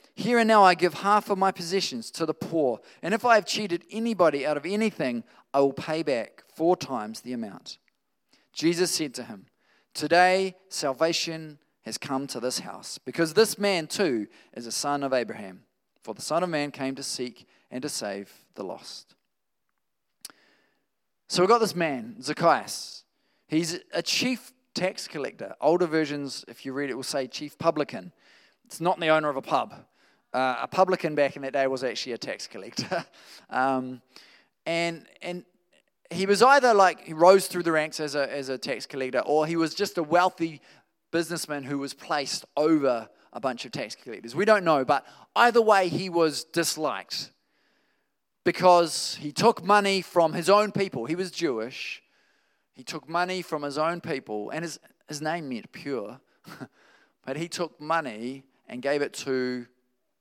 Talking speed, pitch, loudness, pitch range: 175 wpm, 165 Hz, -26 LUFS, 140-185 Hz